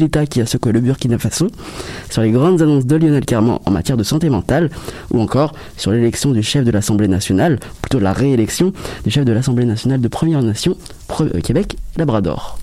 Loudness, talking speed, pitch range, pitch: -16 LUFS, 200 wpm, 110-140 Hz, 120 Hz